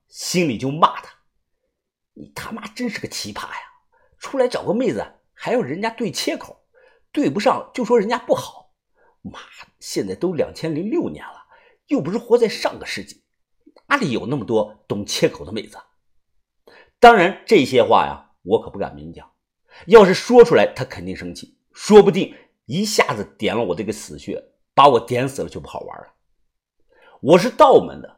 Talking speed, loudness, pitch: 250 characters per minute, -18 LUFS, 240 Hz